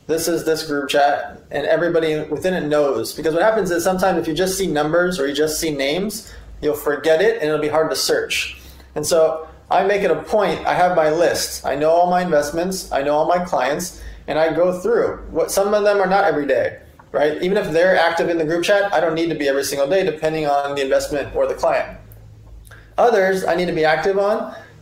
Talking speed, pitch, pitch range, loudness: 235 wpm, 160 Hz, 150-185 Hz, -18 LUFS